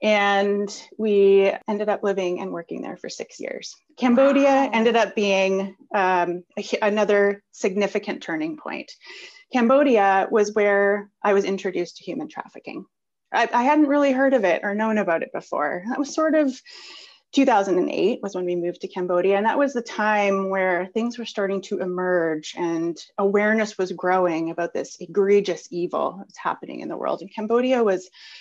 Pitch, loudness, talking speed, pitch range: 205 Hz, -22 LUFS, 170 wpm, 190-240 Hz